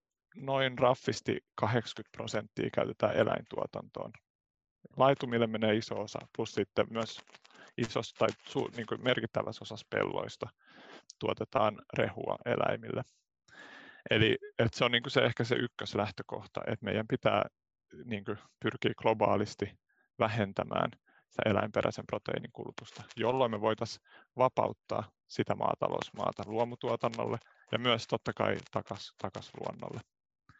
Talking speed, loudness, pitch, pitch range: 110 wpm, -33 LUFS, 115 Hz, 110-130 Hz